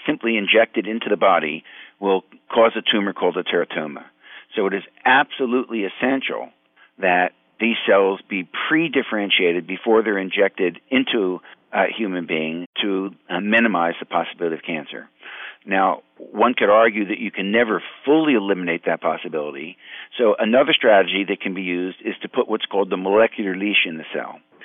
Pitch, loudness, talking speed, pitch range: 100 Hz, -20 LUFS, 160 wpm, 95-115 Hz